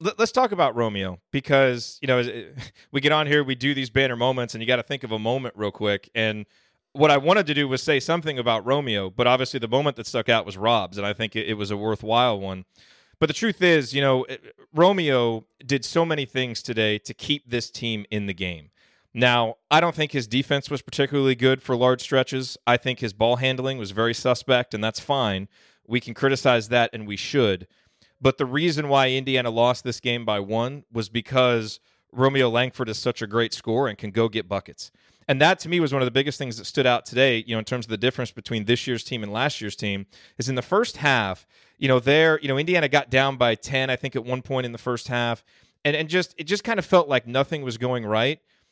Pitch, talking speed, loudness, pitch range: 125 Hz, 240 wpm, -23 LUFS, 115-140 Hz